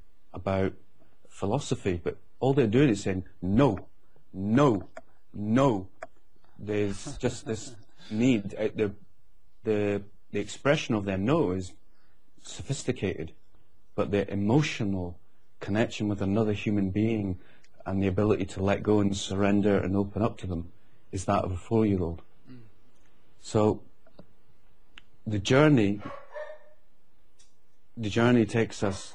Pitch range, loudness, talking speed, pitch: 95-115 Hz, -28 LUFS, 125 wpm, 105 Hz